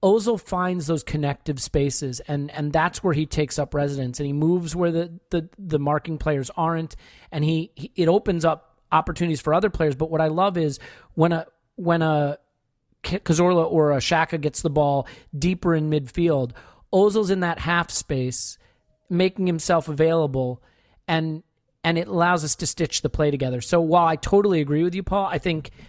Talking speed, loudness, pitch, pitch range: 185 wpm, -23 LUFS, 160 Hz, 145-175 Hz